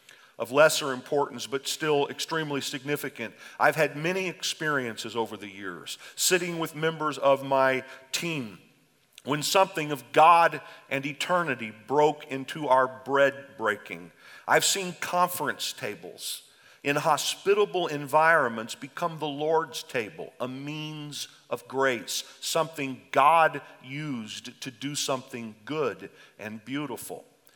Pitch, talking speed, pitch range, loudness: 145 Hz, 120 wpm, 130-160 Hz, -27 LUFS